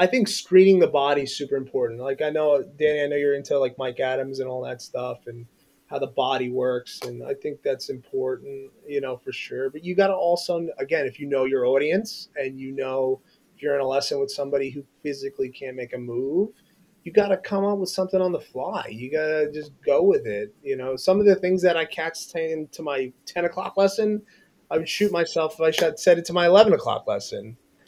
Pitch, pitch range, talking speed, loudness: 160 Hz, 135-195 Hz, 225 wpm, -24 LUFS